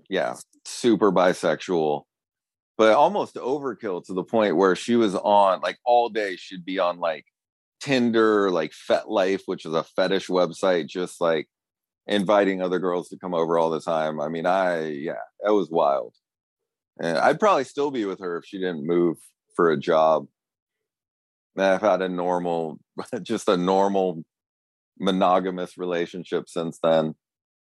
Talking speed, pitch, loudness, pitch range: 155 wpm, 90 Hz, -23 LUFS, 80-100 Hz